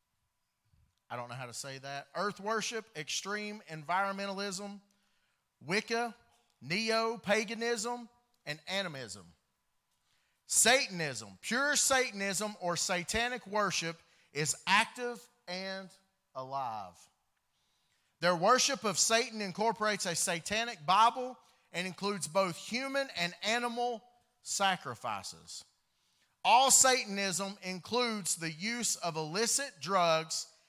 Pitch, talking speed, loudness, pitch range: 195 Hz, 95 wpm, -32 LUFS, 160-230 Hz